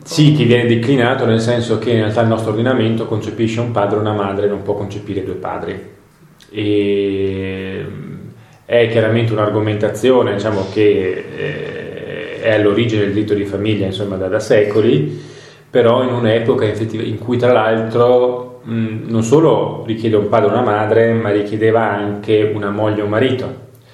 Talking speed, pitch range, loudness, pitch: 155 wpm, 105-125 Hz, -15 LUFS, 110 Hz